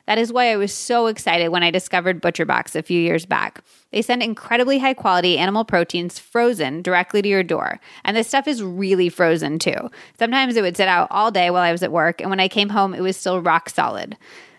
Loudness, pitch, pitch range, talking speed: -19 LUFS, 185 Hz, 175-225 Hz, 230 wpm